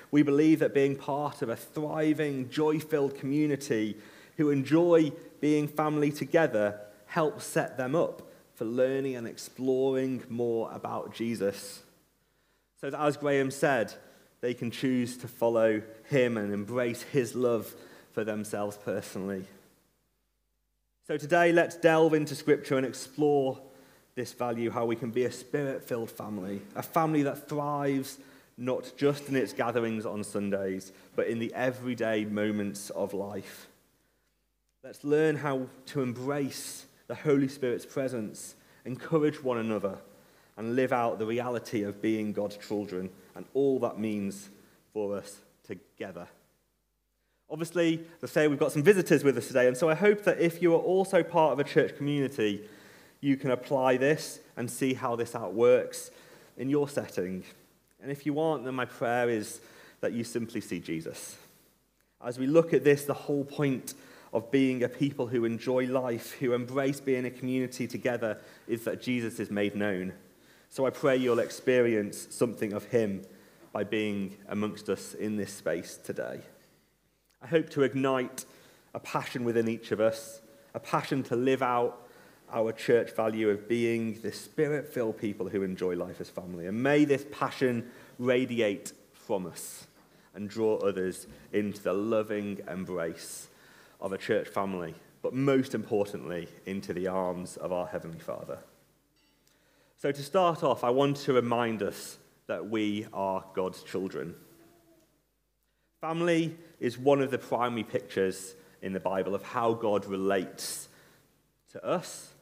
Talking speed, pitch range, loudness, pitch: 155 wpm, 105-140 Hz, -30 LUFS, 125 Hz